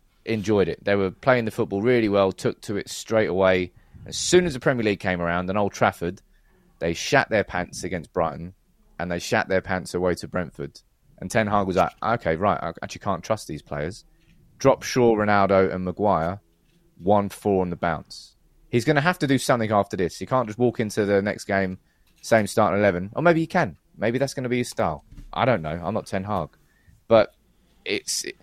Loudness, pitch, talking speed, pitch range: -23 LUFS, 100 Hz, 220 wpm, 90-120 Hz